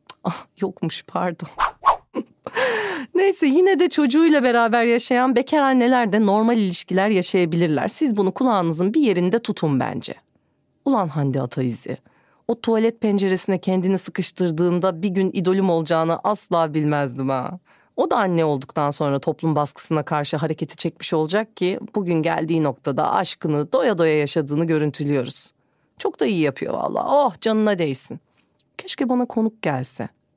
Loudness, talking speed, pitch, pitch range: -20 LUFS, 135 wpm, 180 Hz, 155-230 Hz